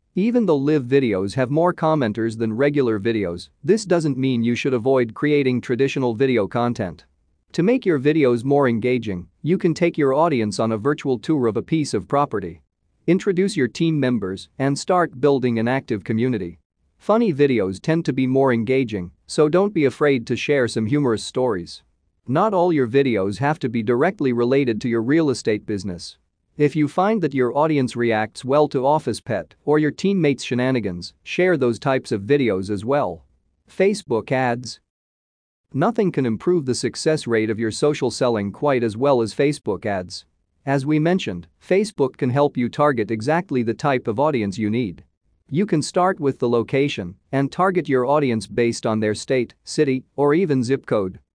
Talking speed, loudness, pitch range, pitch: 180 wpm, -20 LUFS, 110-150 Hz, 130 Hz